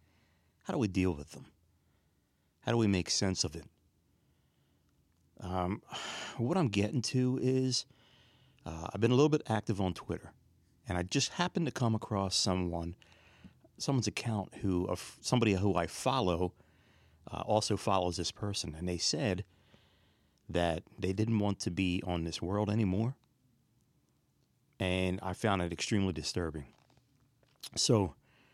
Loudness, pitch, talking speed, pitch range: -33 LUFS, 95 Hz, 145 wpm, 90-120 Hz